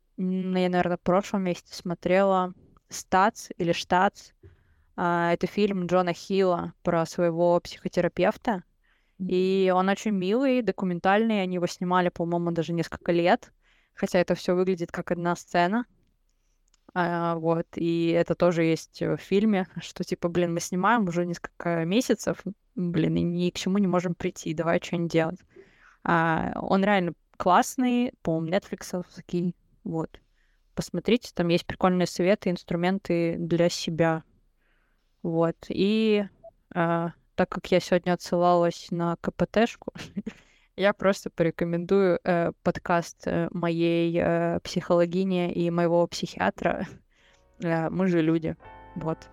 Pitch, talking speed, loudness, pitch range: 175 Hz, 120 wpm, -26 LUFS, 170-190 Hz